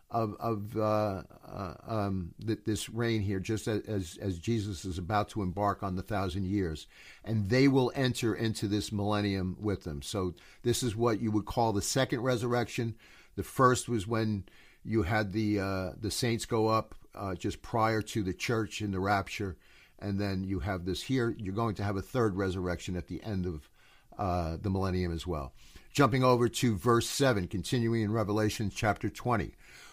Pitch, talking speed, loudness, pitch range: 105 Hz, 185 wpm, -32 LUFS, 95-115 Hz